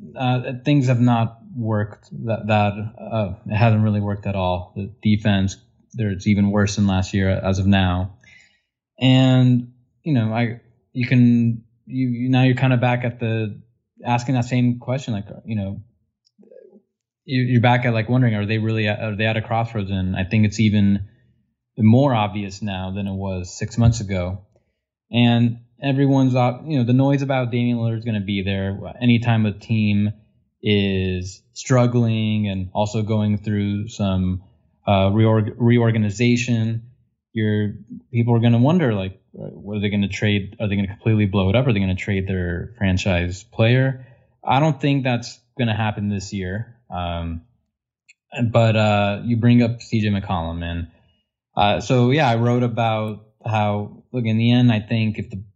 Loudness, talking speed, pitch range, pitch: -20 LUFS, 175 wpm, 100-120 Hz, 110 Hz